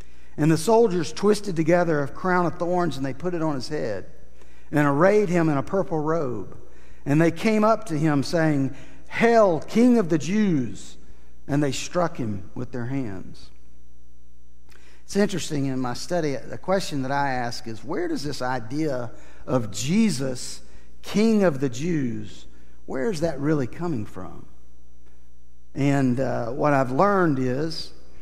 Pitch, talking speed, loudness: 140 Hz, 160 wpm, -24 LUFS